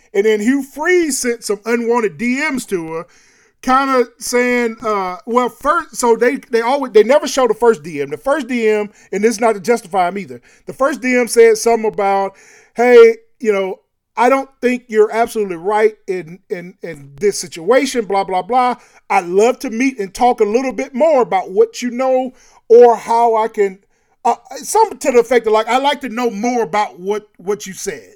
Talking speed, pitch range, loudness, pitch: 200 wpm, 210-255 Hz, -15 LUFS, 235 Hz